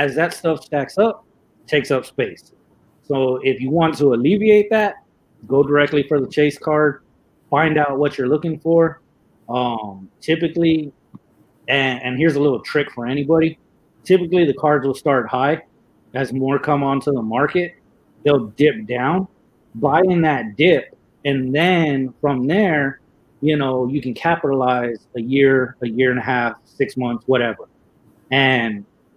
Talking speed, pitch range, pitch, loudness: 155 wpm, 130-160 Hz, 145 Hz, -18 LUFS